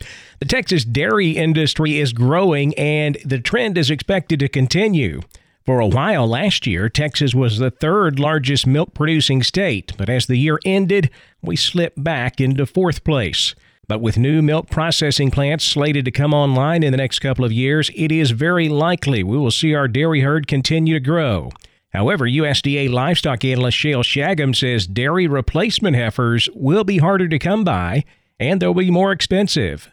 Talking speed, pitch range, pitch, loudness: 175 wpm, 130-165 Hz, 145 Hz, -17 LUFS